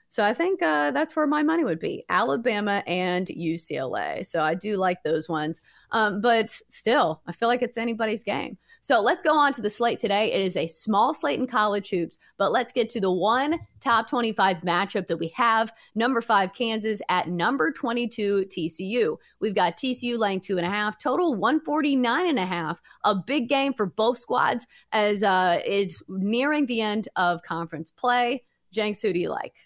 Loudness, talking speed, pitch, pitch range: -25 LUFS, 195 wpm, 215 Hz, 185-245 Hz